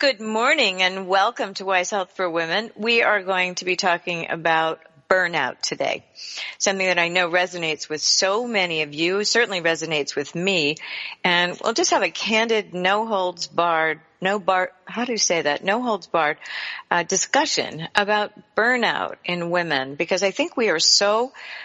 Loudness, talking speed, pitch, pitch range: -21 LUFS, 175 wpm, 185 Hz, 170-210 Hz